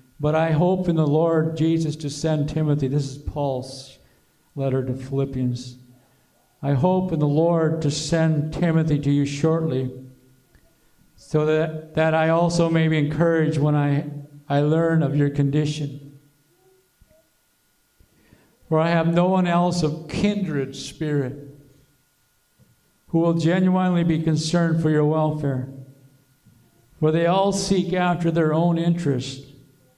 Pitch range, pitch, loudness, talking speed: 140-165 Hz, 155 Hz, -22 LUFS, 135 wpm